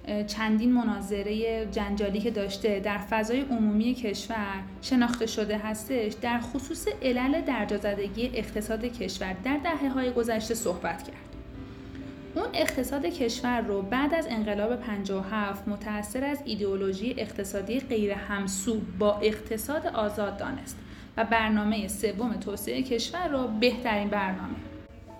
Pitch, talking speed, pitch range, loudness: 220 Hz, 120 wpm, 205-245 Hz, -29 LUFS